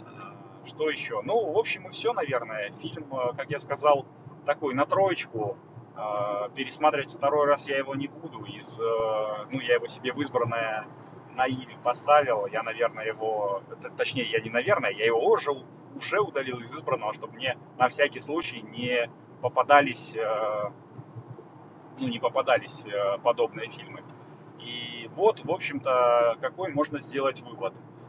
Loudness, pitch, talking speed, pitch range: -27 LUFS, 135 Hz, 140 wpm, 120-155 Hz